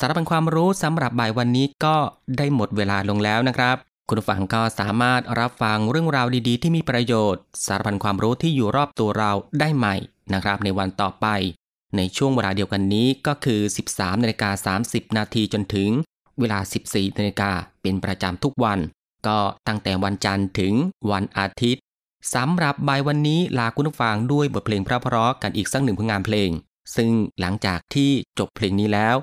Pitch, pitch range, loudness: 110 Hz, 100-130 Hz, -22 LUFS